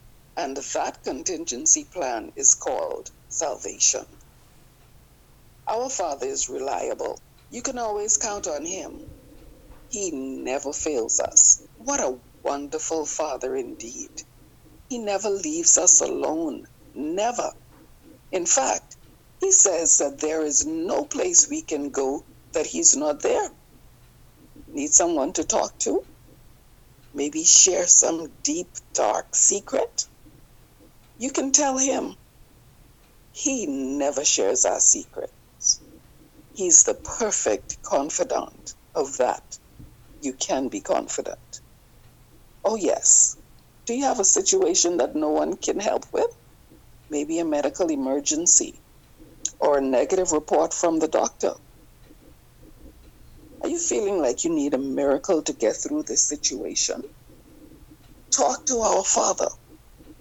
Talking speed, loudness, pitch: 120 wpm, -21 LUFS, 290 Hz